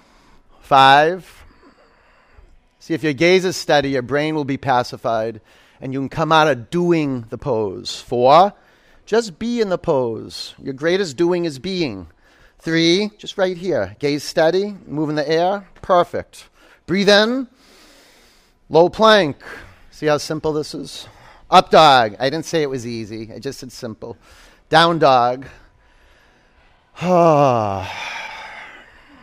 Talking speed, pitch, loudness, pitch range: 135 wpm, 155 Hz, -17 LUFS, 130-175 Hz